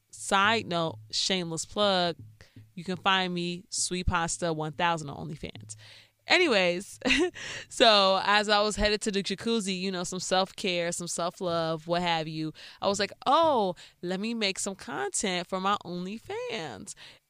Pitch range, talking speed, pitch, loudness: 165-200 Hz, 155 wpm, 180 Hz, -27 LUFS